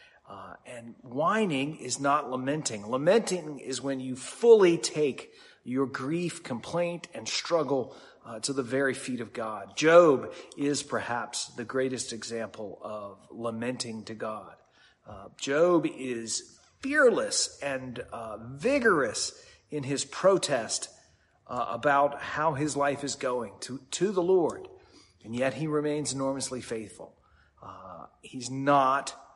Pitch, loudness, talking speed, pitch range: 140 Hz, -28 LUFS, 130 wpm, 125-165 Hz